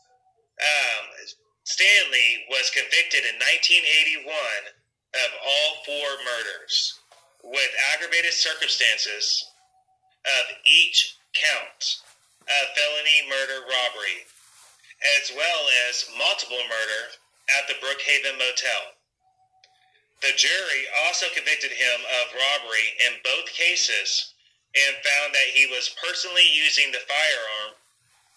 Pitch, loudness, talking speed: 150 Hz, -21 LUFS, 100 wpm